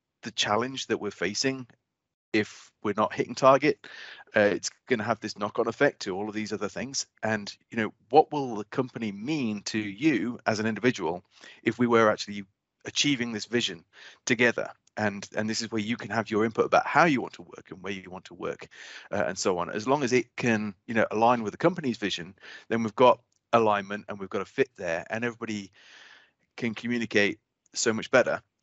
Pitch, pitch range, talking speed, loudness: 110 Hz, 105-120 Hz, 210 wpm, -27 LUFS